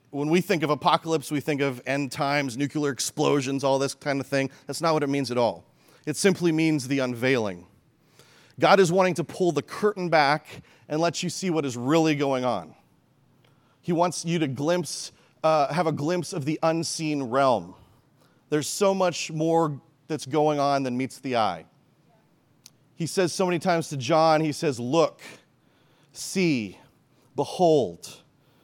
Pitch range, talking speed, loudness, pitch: 135-165 Hz, 170 wpm, -25 LUFS, 150 Hz